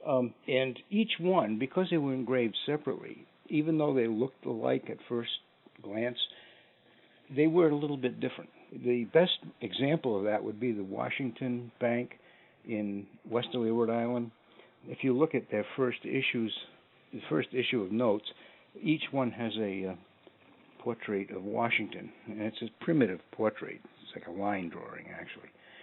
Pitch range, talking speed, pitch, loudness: 110-135 Hz, 160 wpm, 120 Hz, -32 LUFS